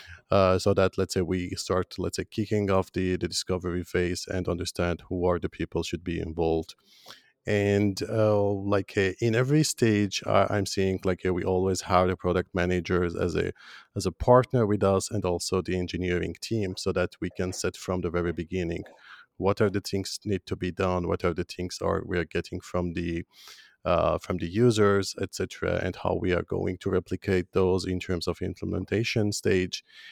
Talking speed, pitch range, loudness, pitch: 195 wpm, 90-100 Hz, -27 LUFS, 95 Hz